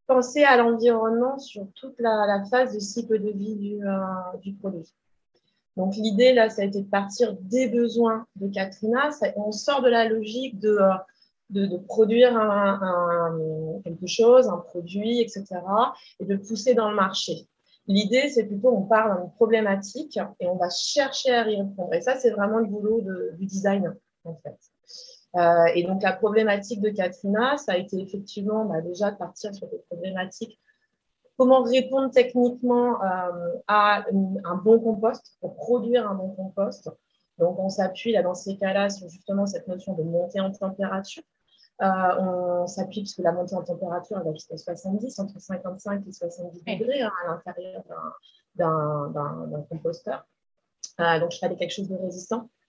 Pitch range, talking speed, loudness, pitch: 180-230 Hz, 180 wpm, -24 LUFS, 200 Hz